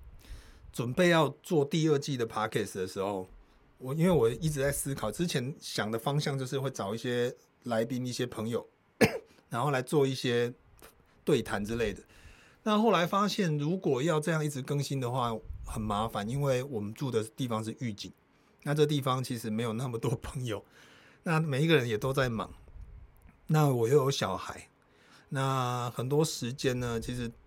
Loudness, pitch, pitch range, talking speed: -31 LUFS, 130 Hz, 115-145 Hz, 265 characters per minute